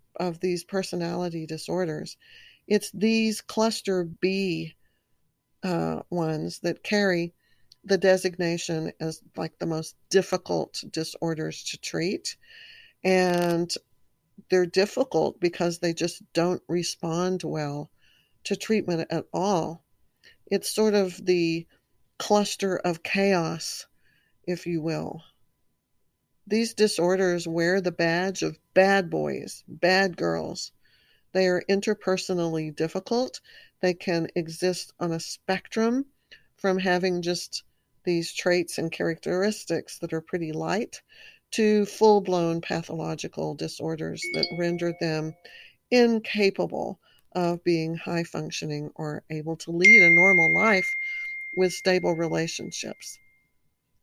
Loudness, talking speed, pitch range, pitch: -25 LUFS, 110 wpm, 165-195 Hz, 175 Hz